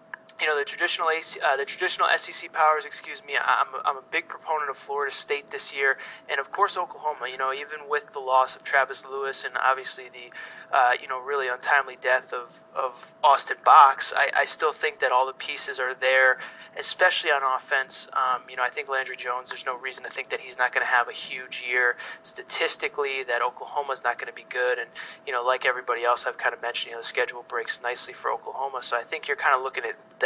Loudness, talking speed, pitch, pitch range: -25 LUFS, 235 wpm, 135 Hz, 130-150 Hz